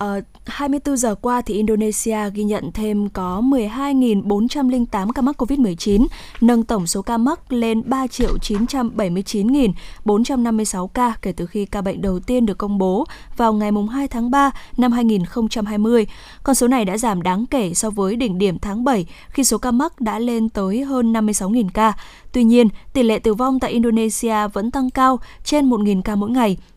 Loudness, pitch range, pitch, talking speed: -19 LUFS, 205-250 Hz, 225 Hz, 175 wpm